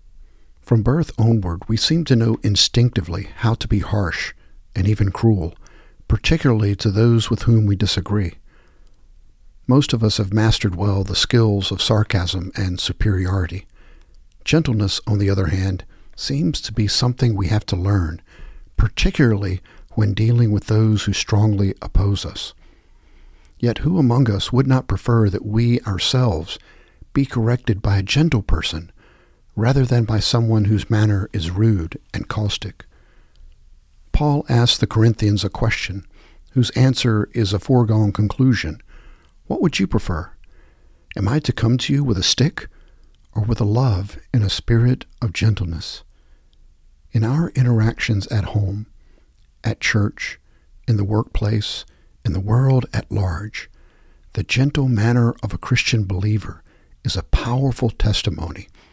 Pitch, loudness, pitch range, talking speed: 105 Hz, -19 LUFS, 95-115 Hz, 145 wpm